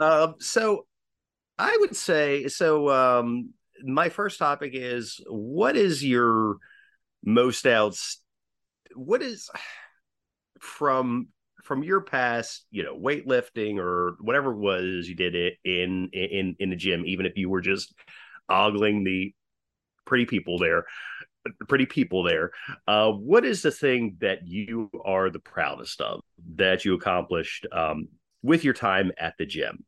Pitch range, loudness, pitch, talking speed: 95-140 Hz, -25 LUFS, 115 Hz, 145 wpm